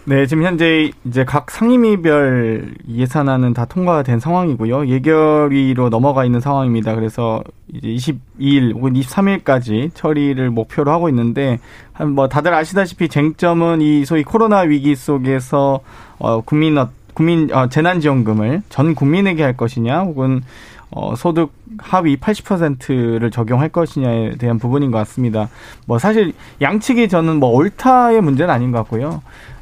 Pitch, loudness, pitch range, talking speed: 140 Hz, -15 LUFS, 120-160 Hz, 310 characters per minute